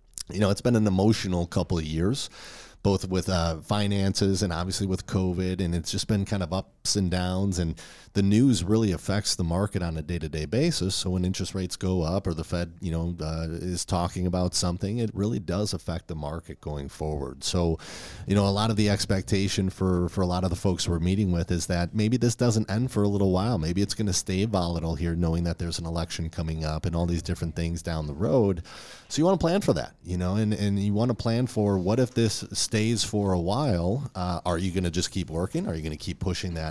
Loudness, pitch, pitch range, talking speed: -27 LUFS, 95 Hz, 85-105 Hz, 245 wpm